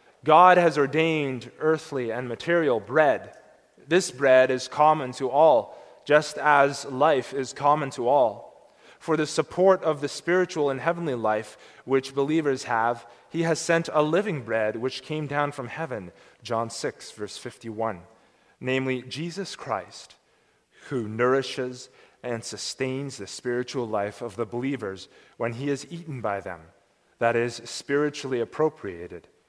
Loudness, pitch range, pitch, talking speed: -25 LUFS, 120-155 Hz, 135 Hz, 140 wpm